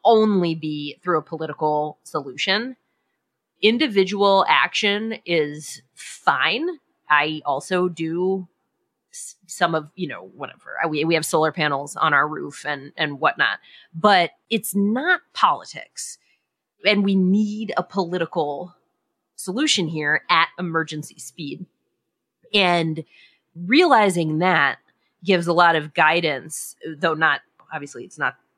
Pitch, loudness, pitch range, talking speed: 175 Hz, -20 LUFS, 155-200 Hz, 120 wpm